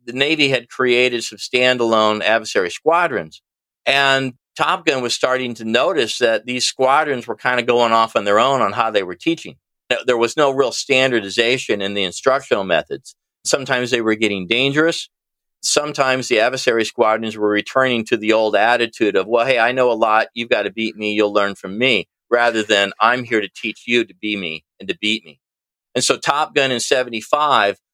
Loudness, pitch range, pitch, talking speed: -17 LUFS, 110-130 Hz, 120 Hz, 195 wpm